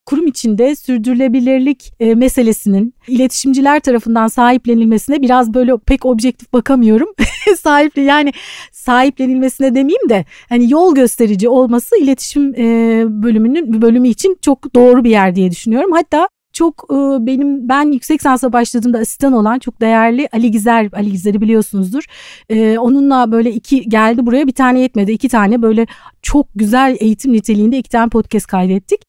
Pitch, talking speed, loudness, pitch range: 250 Hz, 135 wpm, -12 LUFS, 225-275 Hz